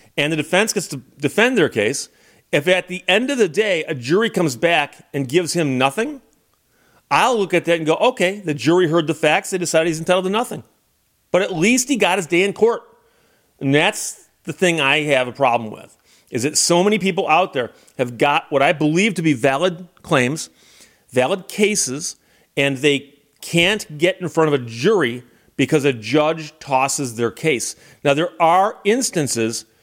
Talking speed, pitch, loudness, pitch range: 195 wpm, 160 Hz, -18 LUFS, 140-185 Hz